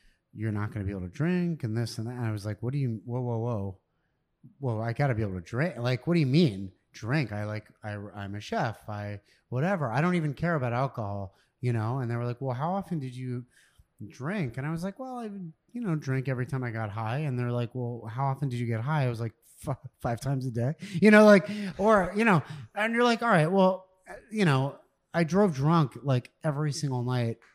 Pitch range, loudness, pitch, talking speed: 115-170 Hz, -28 LUFS, 130 Hz, 250 wpm